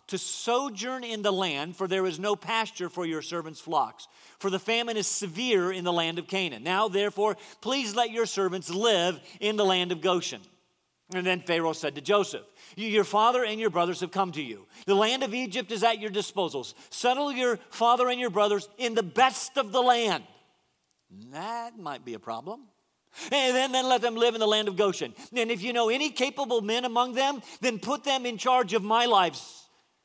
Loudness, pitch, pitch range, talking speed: -27 LUFS, 215 Hz, 185-245 Hz, 210 wpm